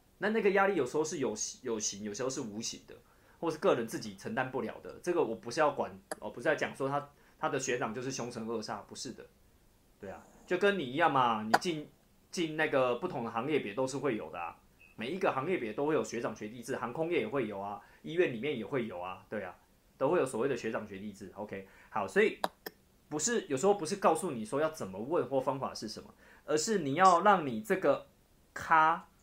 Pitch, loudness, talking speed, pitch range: 135 Hz, -33 LUFS, 330 characters per minute, 115-170 Hz